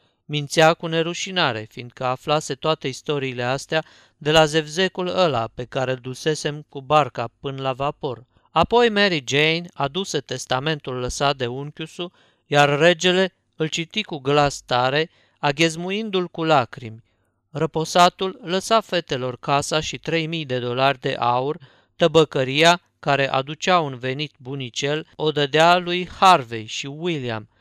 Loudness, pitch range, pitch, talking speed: -21 LUFS, 130-170 Hz, 150 Hz, 135 wpm